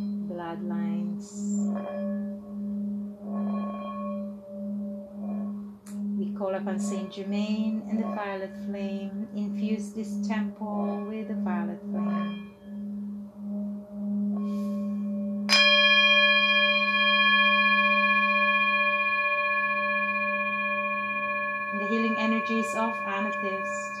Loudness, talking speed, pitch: -26 LUFS, 55 wpm, 205 Hz